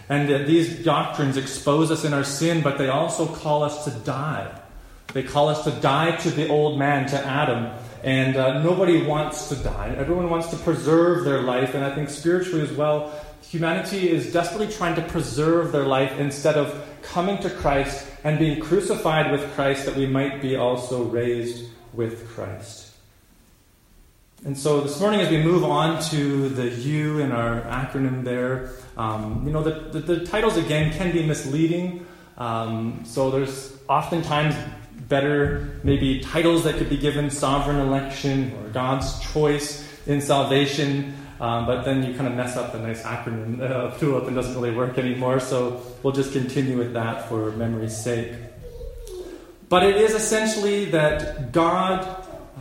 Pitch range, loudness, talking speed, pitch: 125-160 Hz, -23 LUFS, 170 wpm, 140 Hz